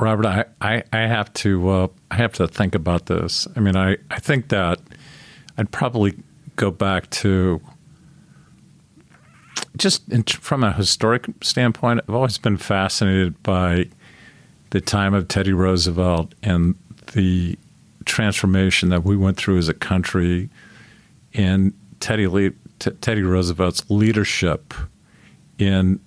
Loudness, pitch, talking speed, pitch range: -20 LUFS, 100 Hz, 135 wpm, 95-110 Hz